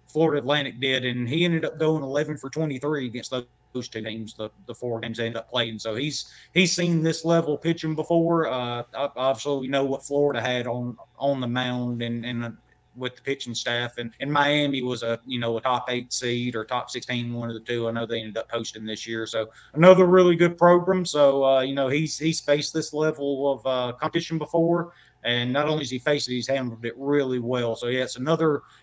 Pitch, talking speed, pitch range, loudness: 130 Hz, 230 wpm, 120-150 Hz, -24 LUFS